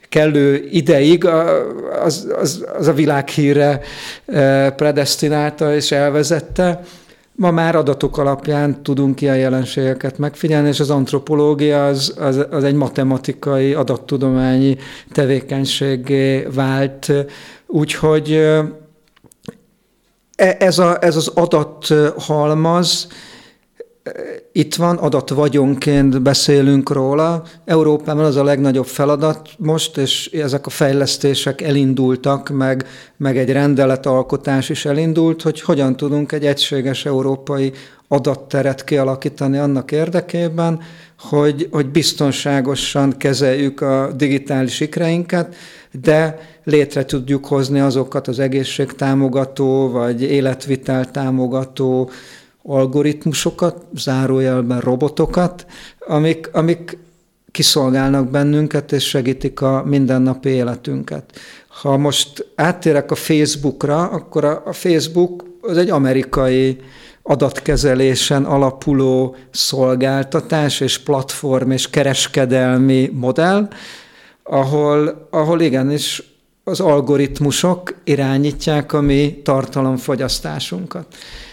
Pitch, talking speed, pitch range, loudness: 145 Hz, 90 wpm, 135-155 Hz, -16 LUFS